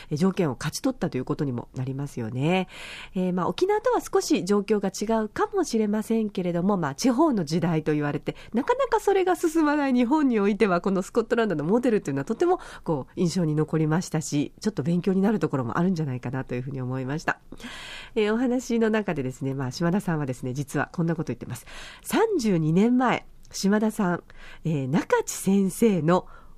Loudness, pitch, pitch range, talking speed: -25 LUFS, 185 Hz, 150-230 Hz, 425 characters per minute